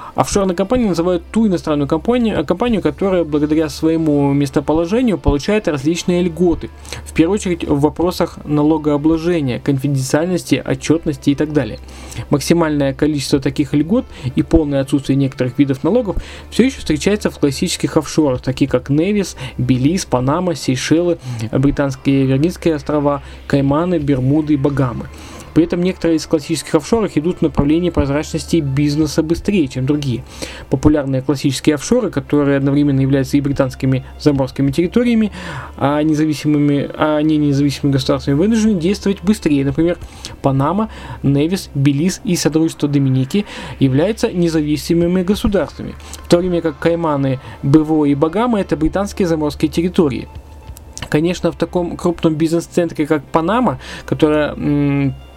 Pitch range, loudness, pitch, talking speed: 140-170 Hz, -16 LUFS, 155 Hz, 130 wpm